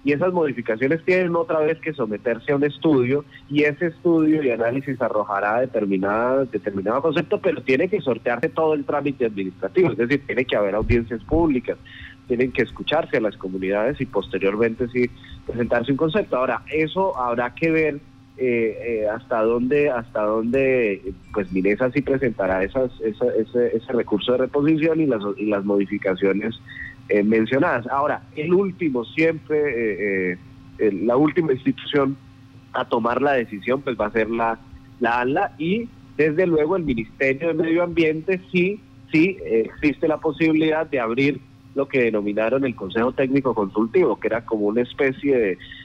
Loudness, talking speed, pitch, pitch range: -21 LUFS, 165 wpm, 130 Hz, 115-150 Hz